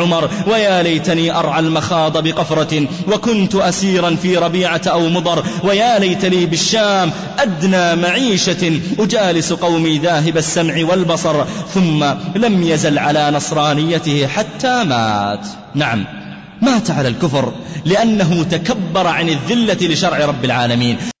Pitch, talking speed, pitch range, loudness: 170 Hz, 110 wpm, 155-190 Hz, -15 LUFS